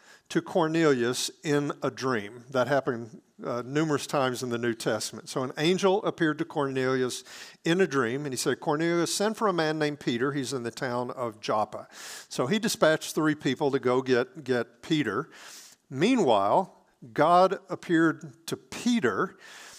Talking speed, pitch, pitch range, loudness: 165 wpm, 145 Hz, 125-165 Hz, -27 LUFS